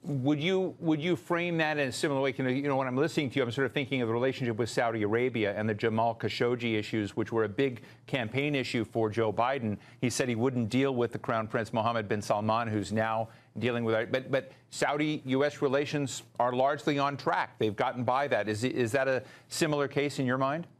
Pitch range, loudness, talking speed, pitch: 115-140 Hz, -30 LUFS, 230 wpm, 130 Hz